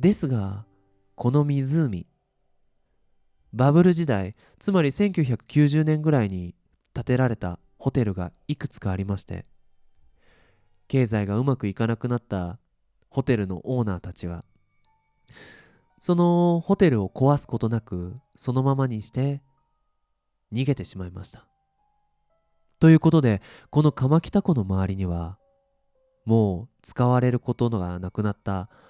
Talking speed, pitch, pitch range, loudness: 245 characters per minute, 120 Hz, 95-150 Hz, -24 LUFS